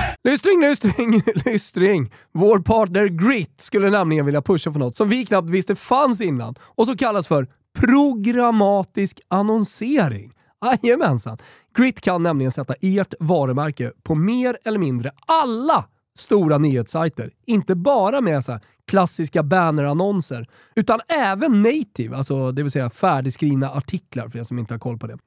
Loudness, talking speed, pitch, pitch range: -19 LUFS, 145 wpm, 185 Hz, 135-220 Hz